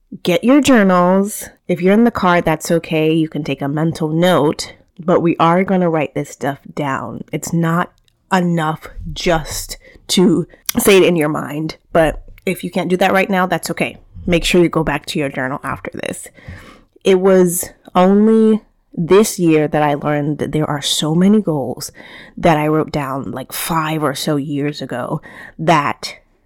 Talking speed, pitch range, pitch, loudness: 180 wpm, 150-185 Hz, 165 Hz, -16 LUFS